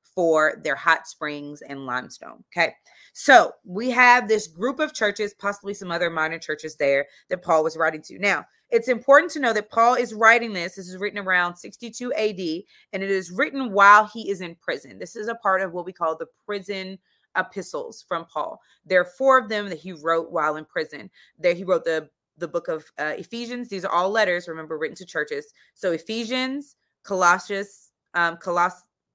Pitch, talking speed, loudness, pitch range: 185 Hz, 200 wpm, -22 LUFS, 165-220 Hz